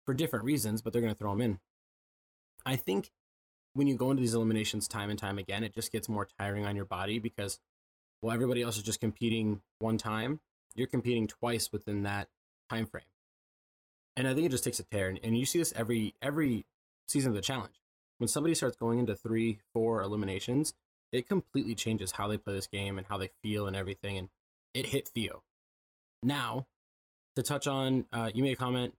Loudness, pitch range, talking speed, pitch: -34 LUFS, 100-125 Hz, 205 wpm, 110 Hz